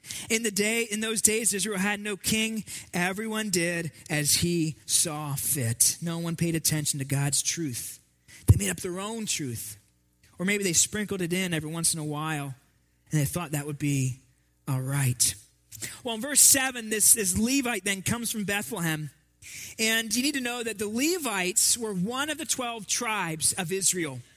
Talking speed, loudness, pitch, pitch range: 185 wpm, -26 LUFS, 175 Hz, 145-220 Hz